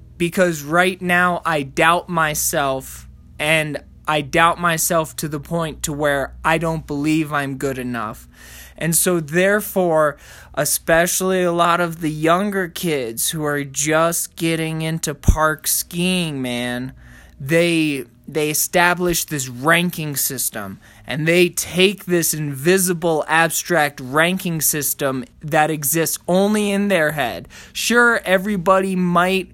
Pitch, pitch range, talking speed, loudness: 160 Hz, 145-175 Hz, 125 wpm, -18 LUFS